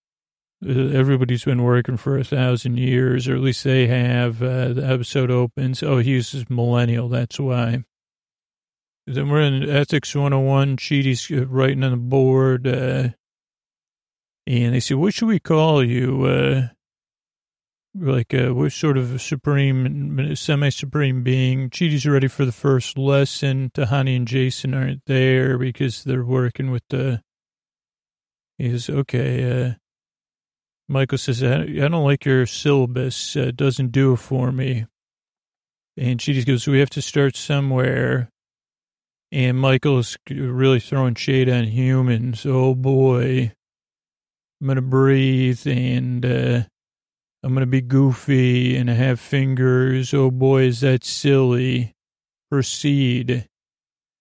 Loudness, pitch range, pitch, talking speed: -19 LUFS, 125-135 Hz, 130 Hz, 135 wpm